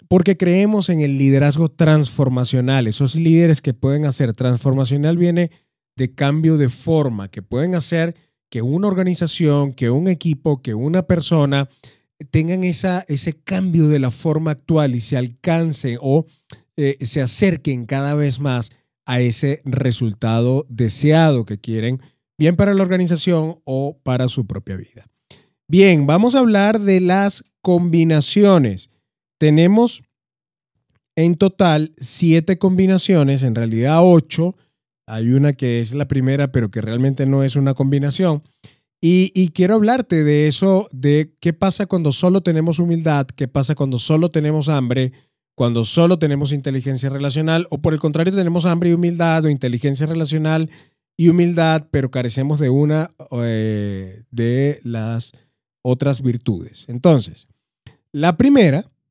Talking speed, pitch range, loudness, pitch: 140 wpm, 130-170 Hz, -17 LUFS, 145 Hz